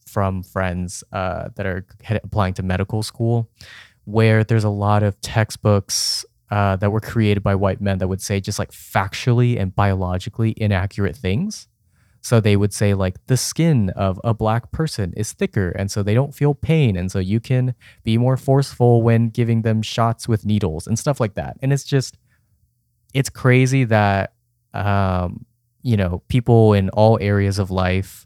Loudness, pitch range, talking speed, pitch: -19 LUFS, 100-120 Hz, 180 wpm, 105 Hz